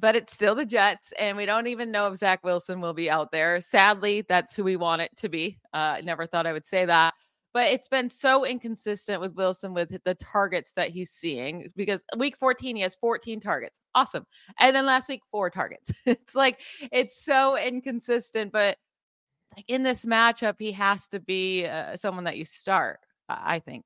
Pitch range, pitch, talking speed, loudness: 180-240 Hz, 205 Hz, 200 wpm, -25 LUFS